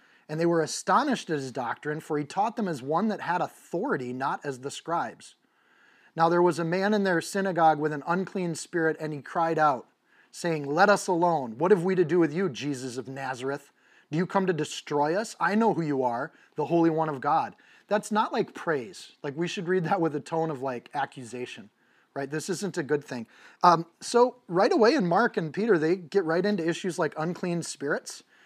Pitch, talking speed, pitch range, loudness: 165 Hz, 215 wpm, 150-190 Hz, -27 LUFS